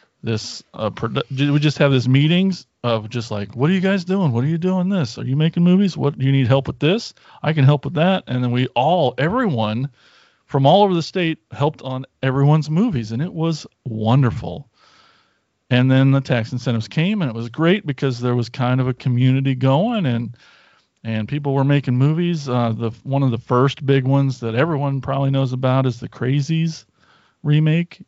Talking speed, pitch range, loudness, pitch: 205 wpm, 125-155 Hz, -19 LUFS, 135 Hz